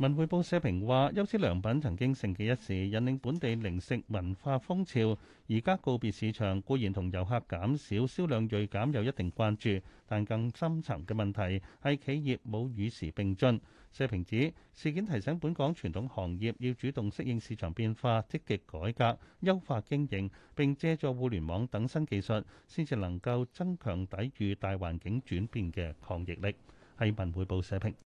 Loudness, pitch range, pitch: -34 LUFS, 100-135 Hz, 115 Hz